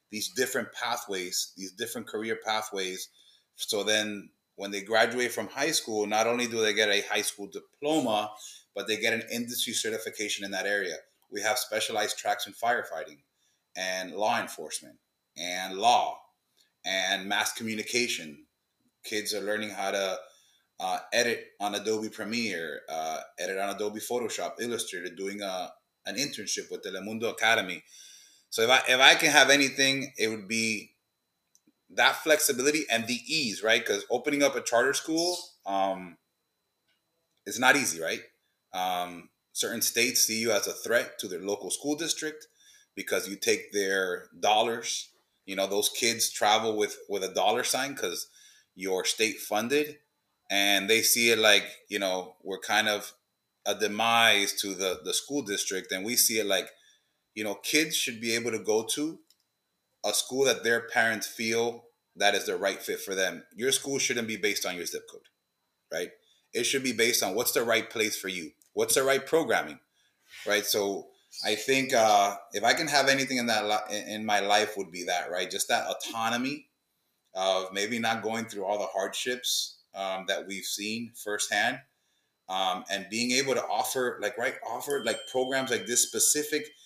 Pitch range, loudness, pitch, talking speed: 100-135 Hz, -28 LUFS, 110 Hz, 170 wpm